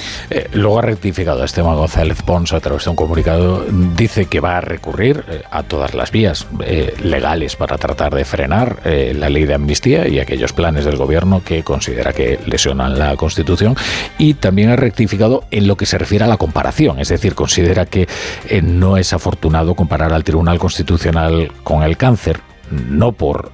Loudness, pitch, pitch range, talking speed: -15 LUFS, 85 Hz, 80-100 Hz, 185 wpm